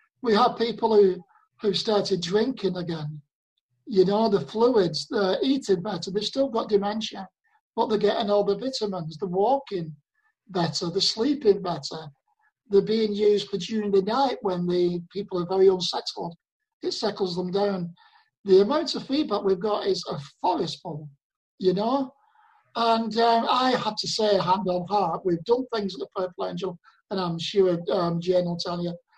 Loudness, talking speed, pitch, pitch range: -25 LUFS, 175 wpm, 200 Hz, 180-230 Hz